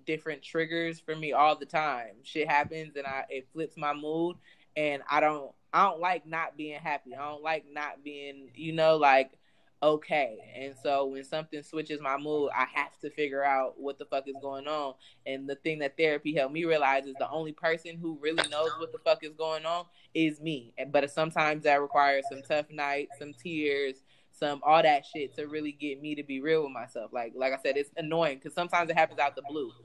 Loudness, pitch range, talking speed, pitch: -30 LUFS, 140-160 Hz, 220 wpm, 150 Hz